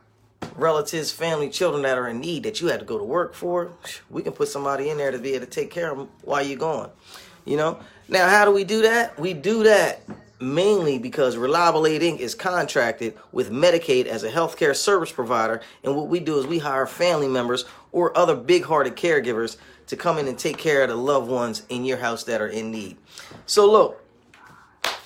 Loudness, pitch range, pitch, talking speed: -22 LUFS, 125-205 Hz, 155 Hz, 215 wpm